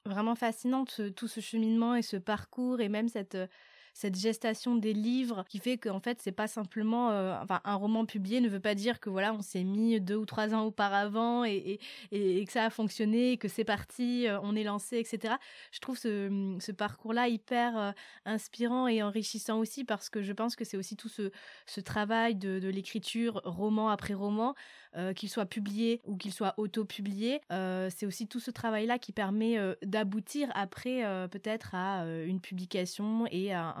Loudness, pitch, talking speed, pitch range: -34 LUFS, 215 Hz, 205 wpm, 200-230 Hz